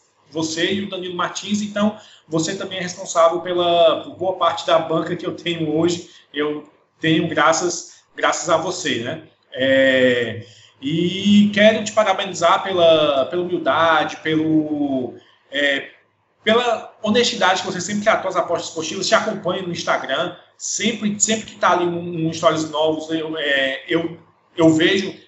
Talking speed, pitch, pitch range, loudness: 150 wpm, 170 Hz, 160-190 Hz, -19 LUFS